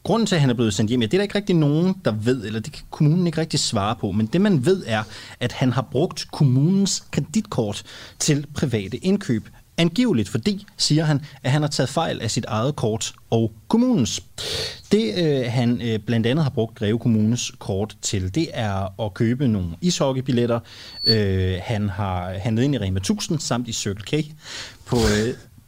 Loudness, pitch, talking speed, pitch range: -22 LUFS, 125 Hz, 200 wpm, 110-155 Hz